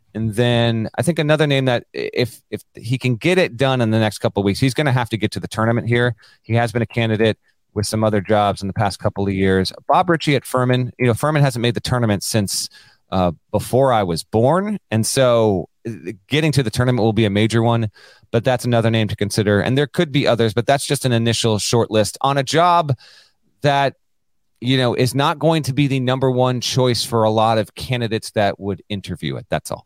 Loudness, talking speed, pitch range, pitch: -18 LUFS, 235 wpm, 110-130 Hz, 115 Hz